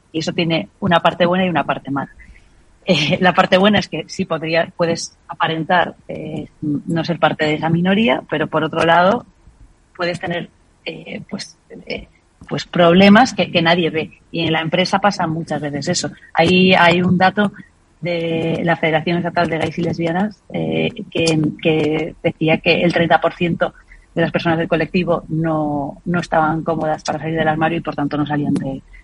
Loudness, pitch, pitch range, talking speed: -17 LUFS, 165 Hz, 160-175 Hz, 180 wpm